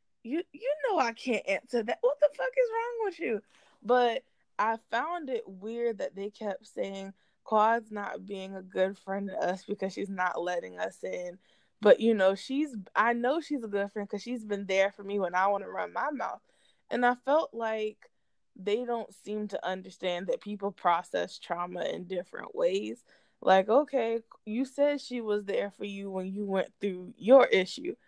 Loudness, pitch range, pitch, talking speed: -30 LUFS, 195-250 Hz, 215 Hz, 195 wpm